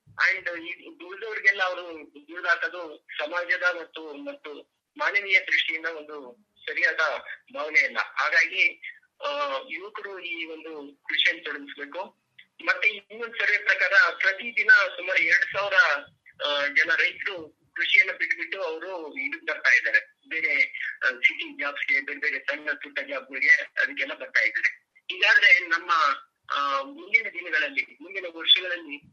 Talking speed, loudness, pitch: 110 wpm, -23 LUFS, 205 Hz